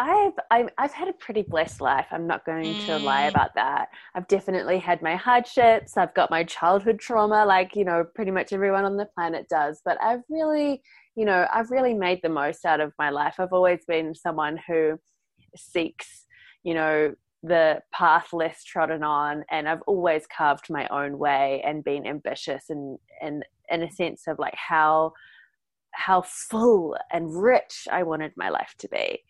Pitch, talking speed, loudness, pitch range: 175 Hz, 180 wpm, -24 LUFS, 160-220 Hz